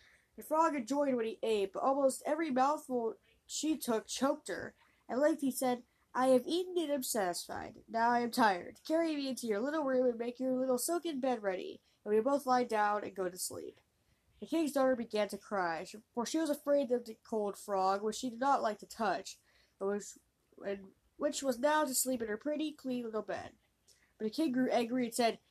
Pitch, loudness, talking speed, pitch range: 255 Hz, -35 LUFS, 215 wpm, 220-290 Hz